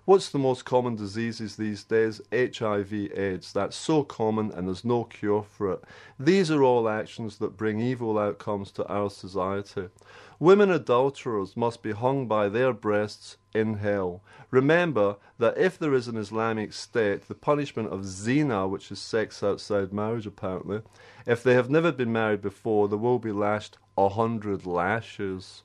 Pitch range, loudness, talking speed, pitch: 100-125 Hz, -27 LUFS, 165 wpm, 110 Hz